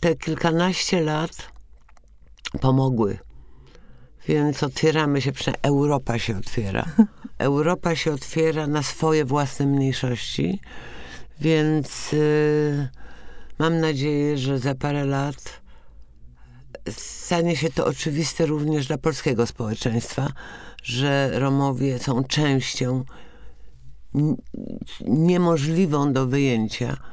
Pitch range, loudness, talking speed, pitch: 125-155 Hz, -23 LUFS, 95 wpm, 140 Hz